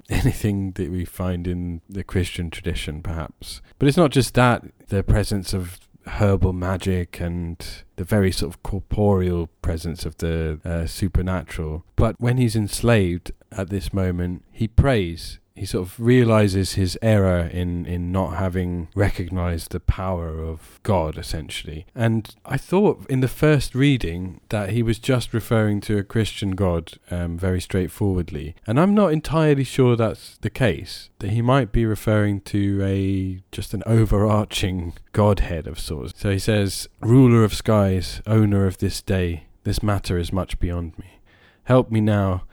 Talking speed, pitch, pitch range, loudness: 160 wpm, 95 Hz, 90-110 Hz, -22 LUFS